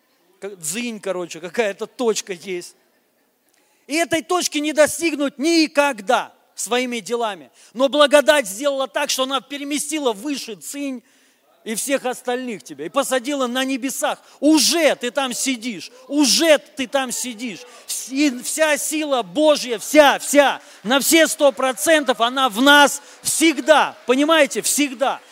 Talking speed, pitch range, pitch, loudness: 130 wpm, 240-295 Hz, 270 Hz, -18 LUFS